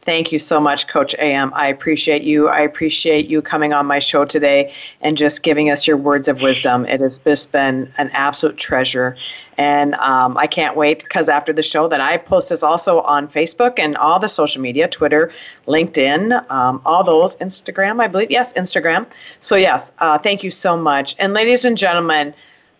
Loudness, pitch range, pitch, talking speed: -15 LUFS, 145-165 Hz, 150 Hz, 195 wpm